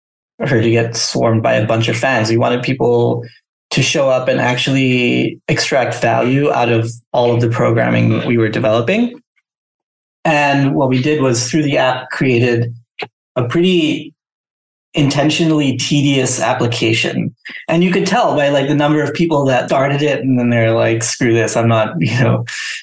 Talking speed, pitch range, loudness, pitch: 175 wpm, 115-145 Hz, -14 LUFS, 125 Hz